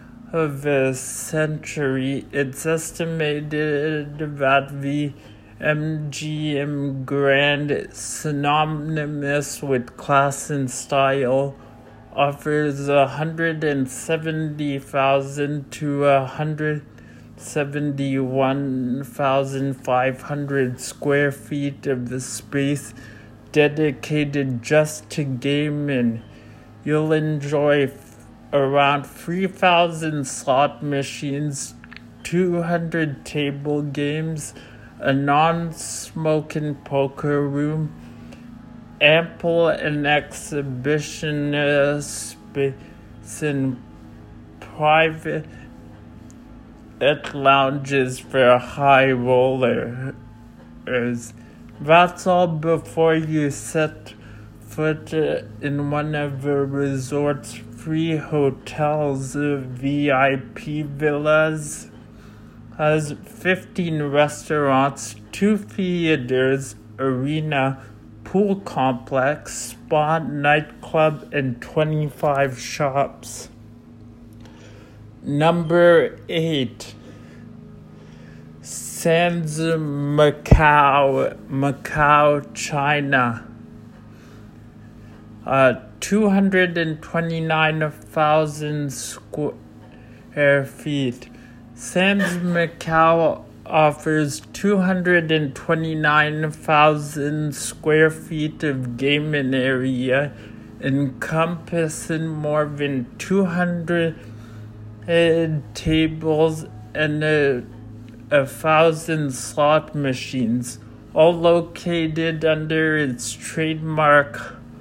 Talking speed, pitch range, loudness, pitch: 65 wpm, 125-155 Hz, -21 LUFS, 145 Hz